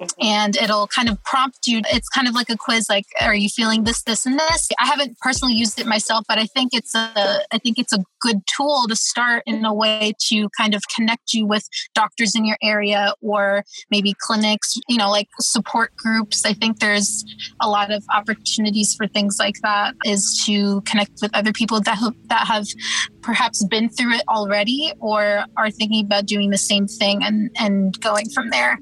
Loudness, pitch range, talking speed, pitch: -18 LUFS, 205-230 Hz, 205 wpm, 220 Hz